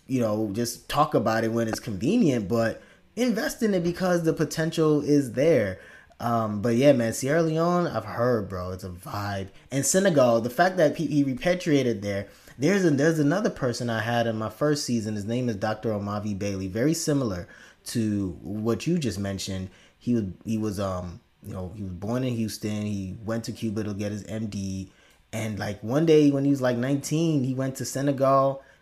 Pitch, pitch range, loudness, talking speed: 115 Hz, 105-145 Hz, -25 LUFS, 200 wpm